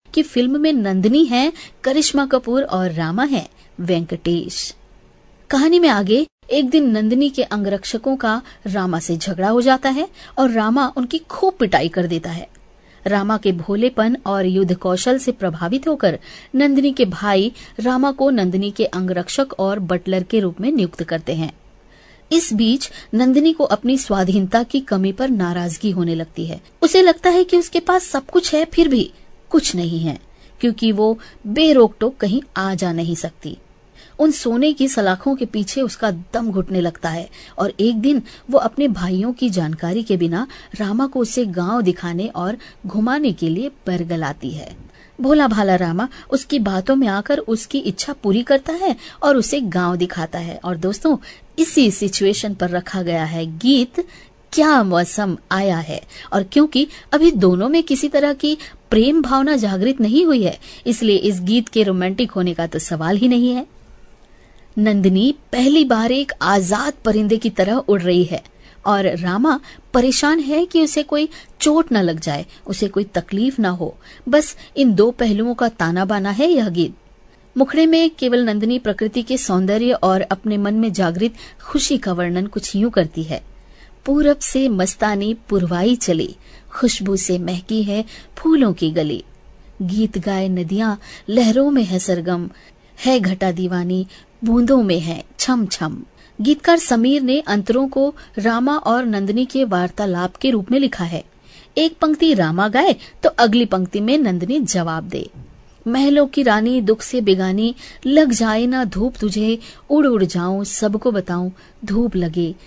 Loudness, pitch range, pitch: -18 LUFS, 185-270 Hz, 220 Hz